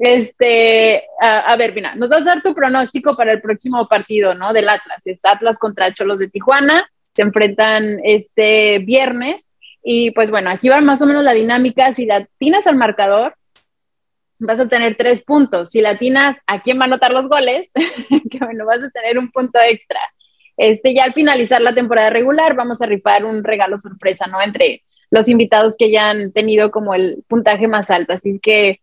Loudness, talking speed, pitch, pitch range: -13 LUFS, 190 wpm, 230 Hz, 210-260 Hz